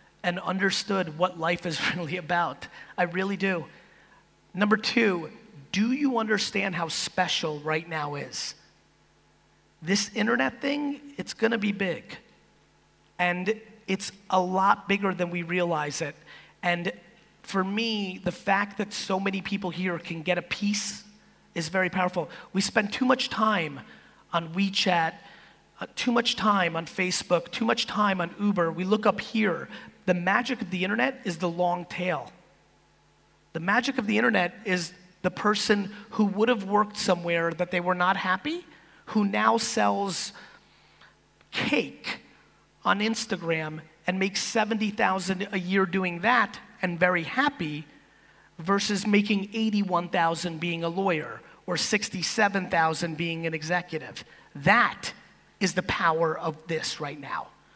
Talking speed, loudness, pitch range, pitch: 140 wpm, -27 LUFS, 175-210 Hz, 190 Hz